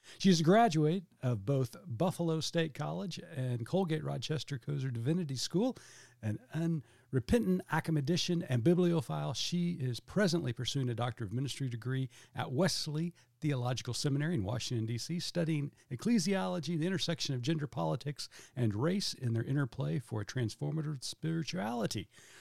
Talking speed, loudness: 140 wpm, -34 LUFS